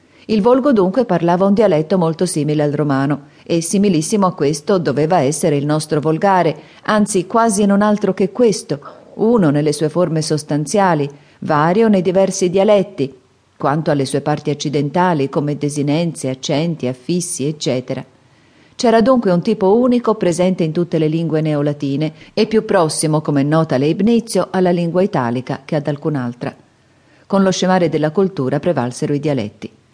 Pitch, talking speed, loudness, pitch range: 160 Hz, 150 wpm, -16 LUFS, 145-195 Hz